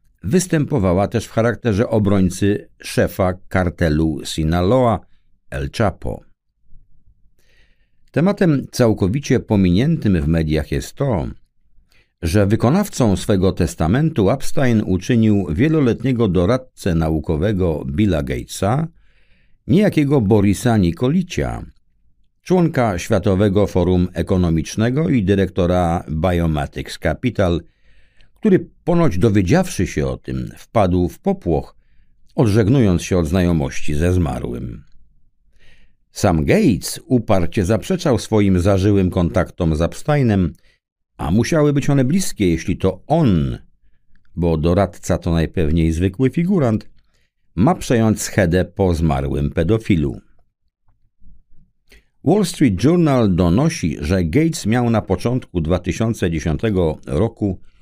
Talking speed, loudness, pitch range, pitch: 100 wpm, -18 LUFS, 85-120 Hz, 100 Hz